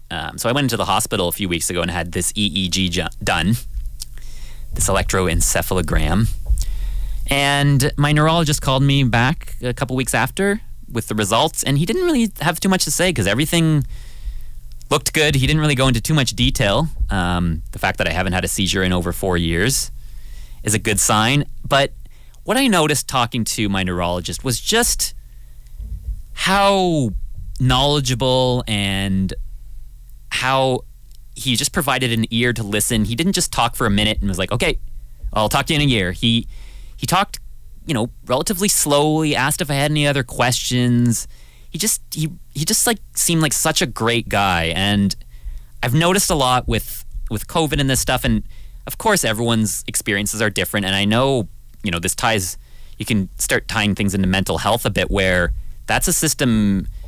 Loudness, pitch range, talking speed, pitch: -18 LUFS, 90-140 Hz, 185 wpm, 110 Hz